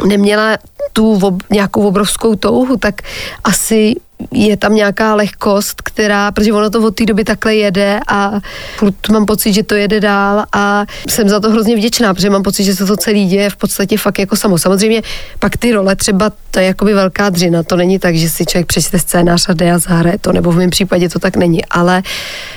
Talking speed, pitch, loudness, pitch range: 205 wpm, 205 Hz, -12 LUFS, 190-215 Hz